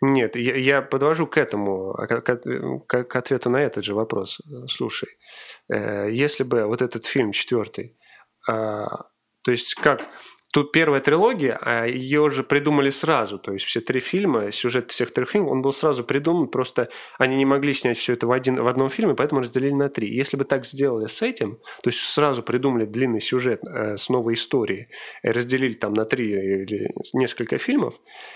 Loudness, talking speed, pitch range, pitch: -22 LUFS, 165 wpm, 115-140 Hz, 130 Hz